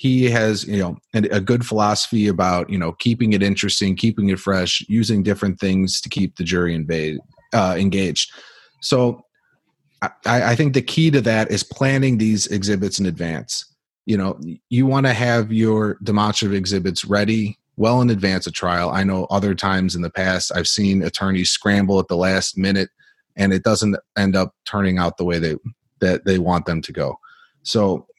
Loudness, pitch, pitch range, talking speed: -19 LUFS, 100 Hz, 95-110 Hz, 185 wpm